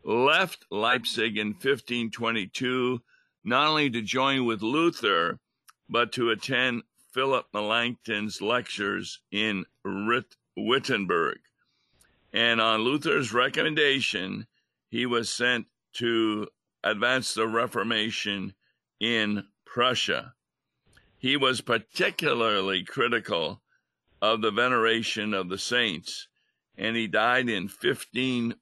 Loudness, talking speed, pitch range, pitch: -26 LUFS, 95 wpm, 110-125 Hz, 115 Hz